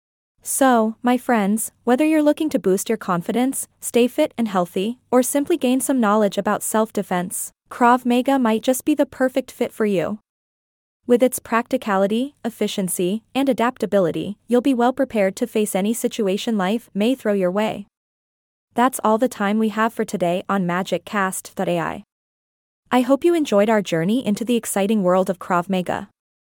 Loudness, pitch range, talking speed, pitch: -20 LUFS, 200-250 Hz, 165 wpm, 220 Hz